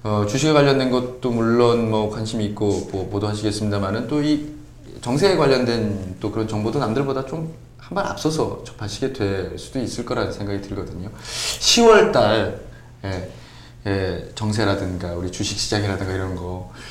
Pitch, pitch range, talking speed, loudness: 110 Hz, 100-125 Hz, 325 characters per minute, -21 LUFS